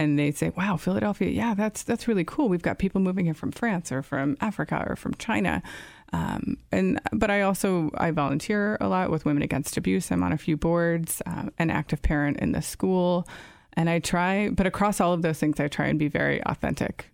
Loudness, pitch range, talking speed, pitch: -26 LUFS, 150-195 Hz, 220 wpm, 170 Hz